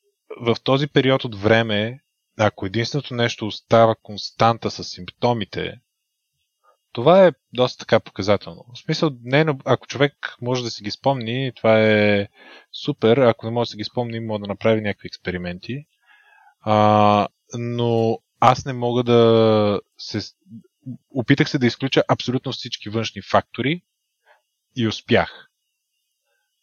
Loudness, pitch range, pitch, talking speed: -20 LUFS, 105-130 Hz, 120 Hz, 135 wpm